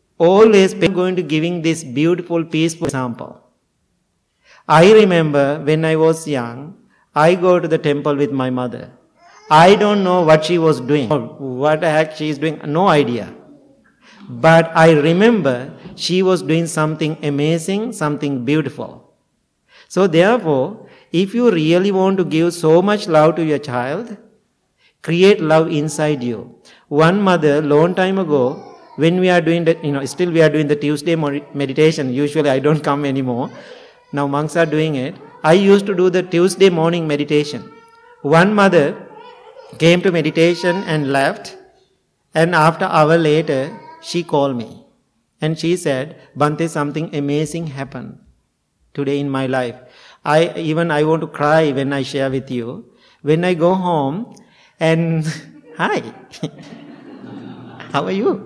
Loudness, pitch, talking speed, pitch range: -16 LUFS, 160 Hz, 155 wpm, 145-180 Hz